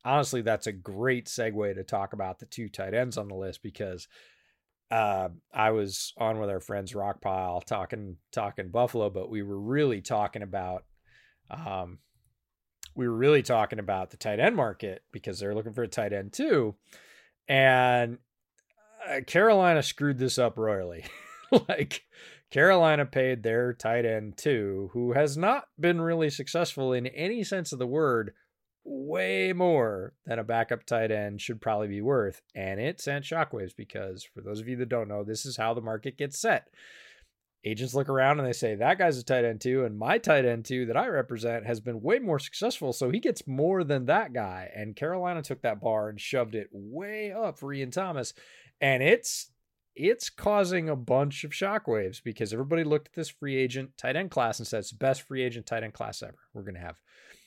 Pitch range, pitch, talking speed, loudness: 105-145 Hz, 120 Hz, 190 wpm, -28 LUFS